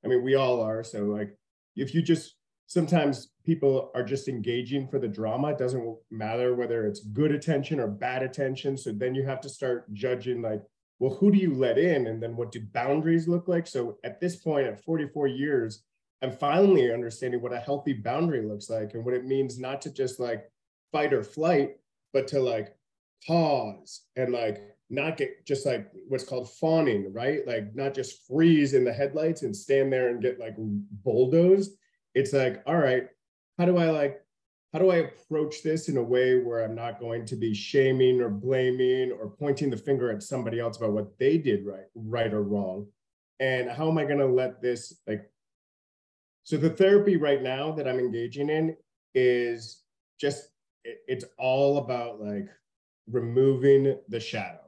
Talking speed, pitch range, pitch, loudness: 190 wpm, 115-145 Hz, 130 Hz, -27 LUFS